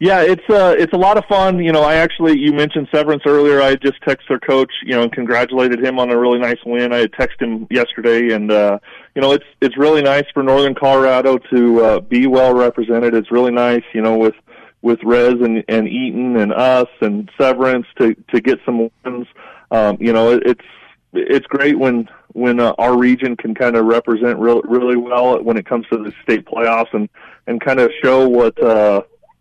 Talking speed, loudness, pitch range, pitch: 215 wpm, -14 LUFS, 115-140 Hz, 125 Hz